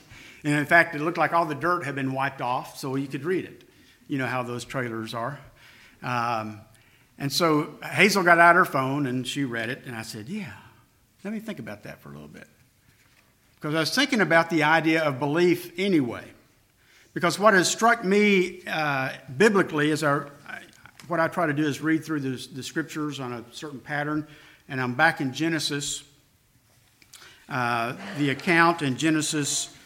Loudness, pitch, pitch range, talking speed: -24 LUFS, 150 Hz, 130-165 Hz, 185 wpm